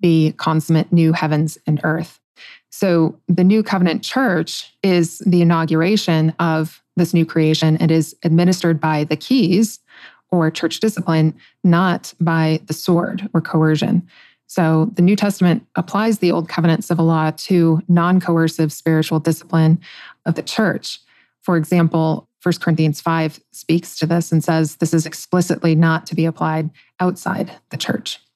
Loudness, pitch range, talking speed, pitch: -17 LUFS, 160-180 Hz, 150 wpm, 165 Hz